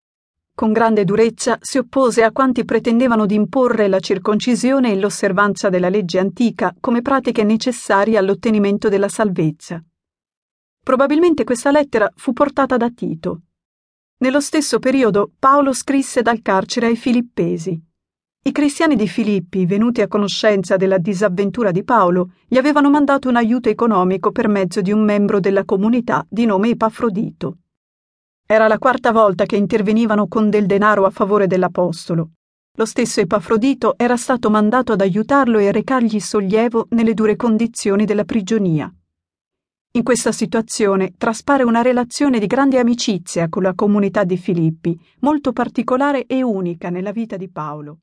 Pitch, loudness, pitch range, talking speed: 220 Hz, -16 LUFS, 200-245 Hz, 145 wpm